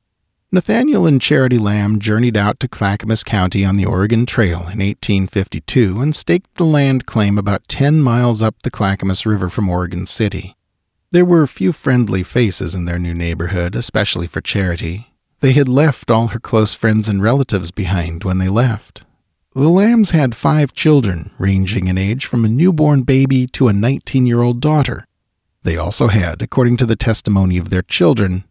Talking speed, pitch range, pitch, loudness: 180 wpm, 95-130 Hz, 110 Hz, -15 LUFS